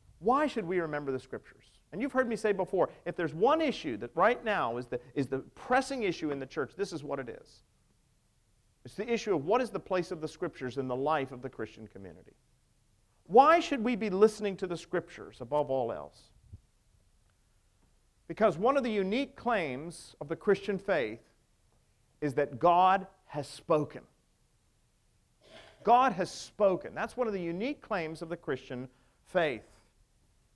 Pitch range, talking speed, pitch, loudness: 125-205 Hz, 175 wpm, 160 Hz, -31 LUFS